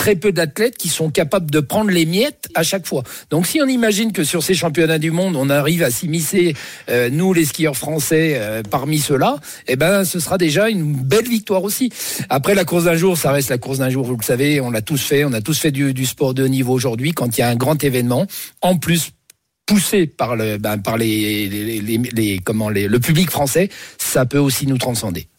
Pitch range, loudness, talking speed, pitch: 130-180 Hz, -17 LUFS, 240 wpm, 155 Hz